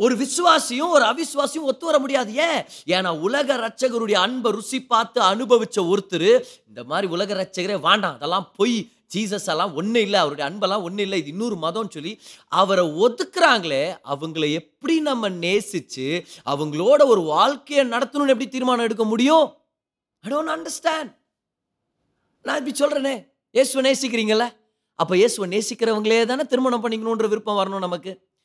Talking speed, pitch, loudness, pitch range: 135 wpm, 230 Hz, -21 LUFS, 195-280 Hz